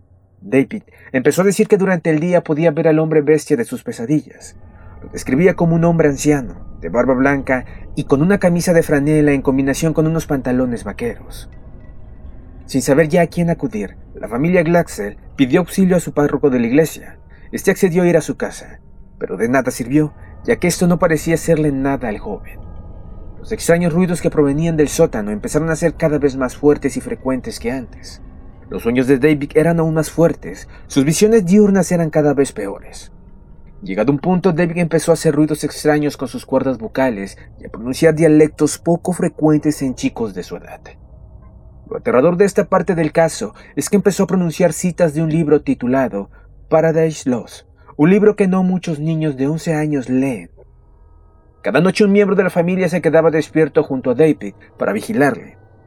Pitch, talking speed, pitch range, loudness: 155 Hz, 190 wpm, 135-175 Hz, -16 LUFS